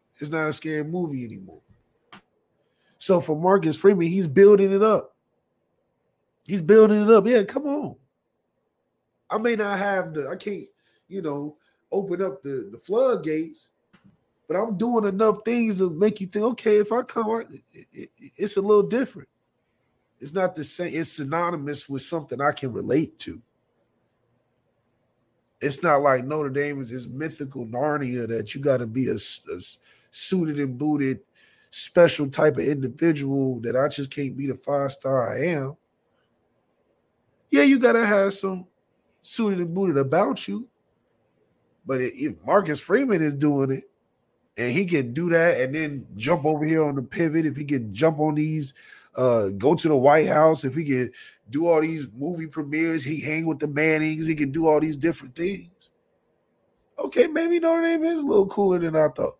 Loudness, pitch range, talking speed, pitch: -23 LUFS, 140-195 Hz, 175 wpm, 155 Hz